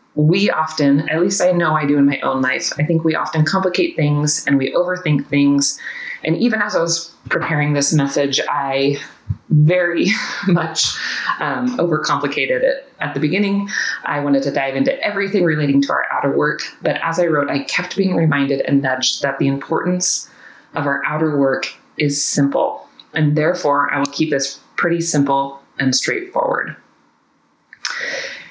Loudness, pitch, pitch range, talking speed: -17 LUFS, 155 Hz, 140-180 Hz, 165 wpm